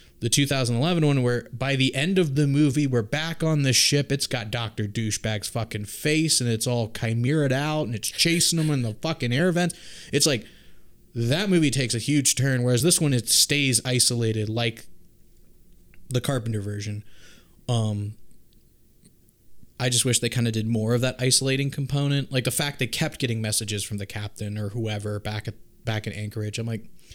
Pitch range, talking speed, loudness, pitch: 110-140 Hz, 190 wpm, -23 LUFS, 125 Hz